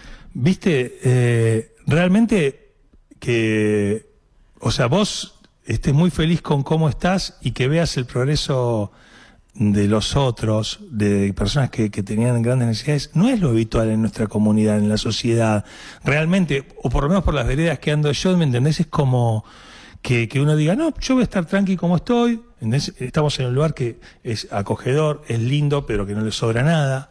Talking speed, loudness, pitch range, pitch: 180 wpm, -20 LUFS, 115-160 Hz, 135 Hz